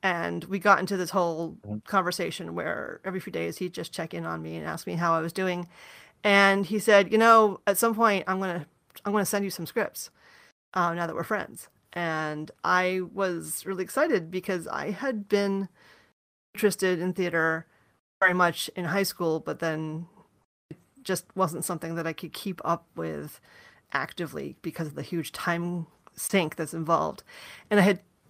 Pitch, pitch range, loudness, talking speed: 180 Hz, 165-195 Hz, -27 LUFS, 185 wpm